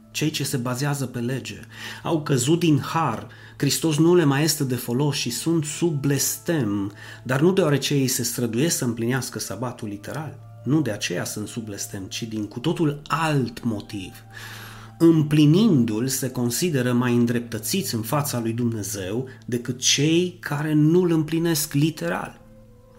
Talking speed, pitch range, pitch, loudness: 155 wpm, 115-150 Hz, 125 Hz, -23 LUFS